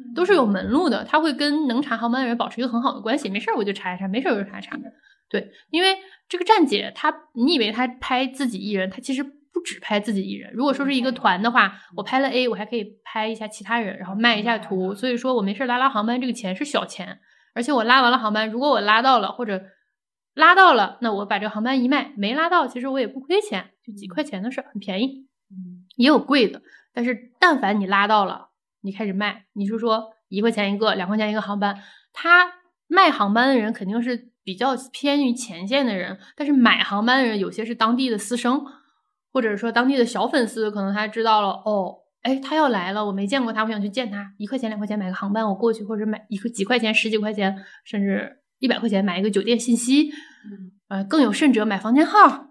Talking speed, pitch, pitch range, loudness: 345 characters per minute, 235 Hz, 210-265 Hz, -21 LUFS